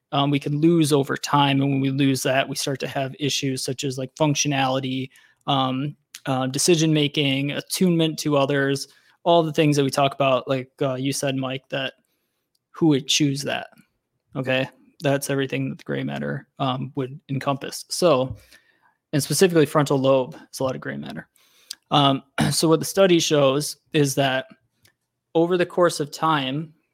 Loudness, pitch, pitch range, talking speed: -22 LUFS, 140 Hz, 135-150 Hz, 170 wpm